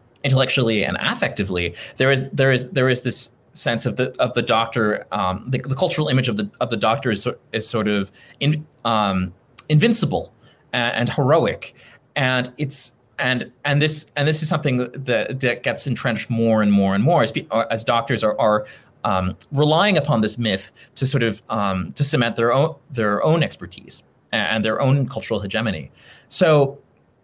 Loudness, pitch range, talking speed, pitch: -20 LUFS, 110-140 Hz, 185 wpm, 125 Hz